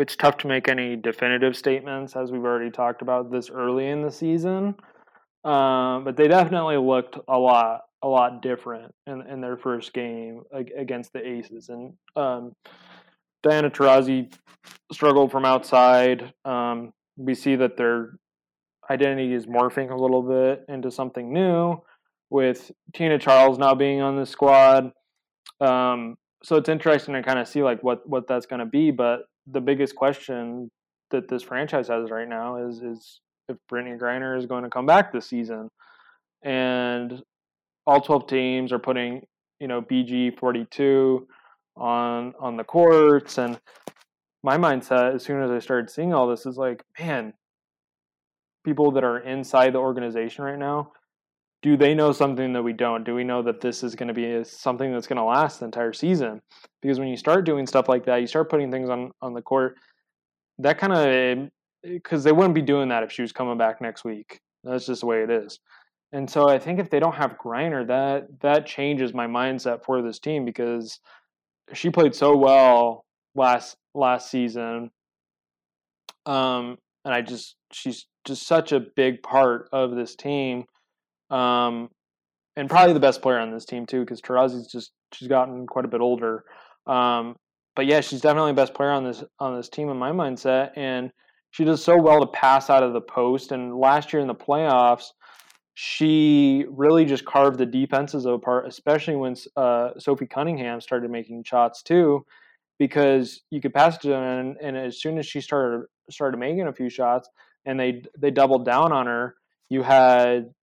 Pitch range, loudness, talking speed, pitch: 120-140 Hz, -22 LUFS, 180 wpm, 130 Hz